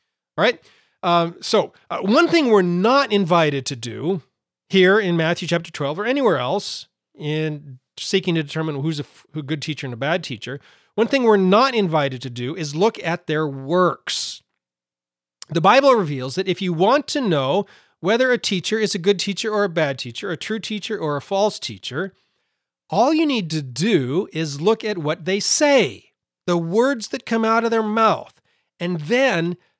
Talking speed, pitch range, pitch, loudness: 190 wpm, 155-215 Hz, 180 Hz, -20 LUFS